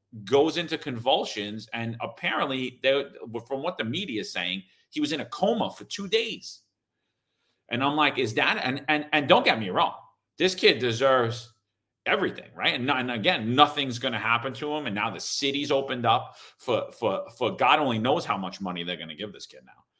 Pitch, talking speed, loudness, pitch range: 130 Hz, 200 wpm, -26 LUFS, 110-145 Hz